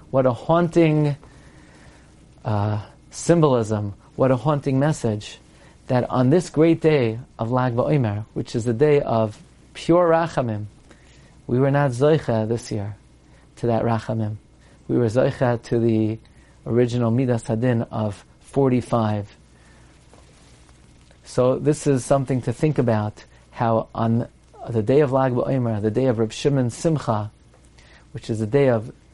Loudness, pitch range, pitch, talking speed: -21 LUFS, 110-140 Hz, 120 Hz, 140 wpm